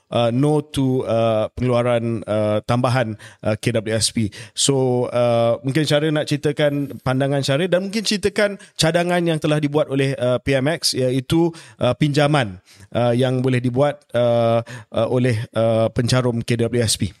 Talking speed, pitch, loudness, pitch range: 135 wpm, 125 Hz, -19 LUFS, 115-145 Hz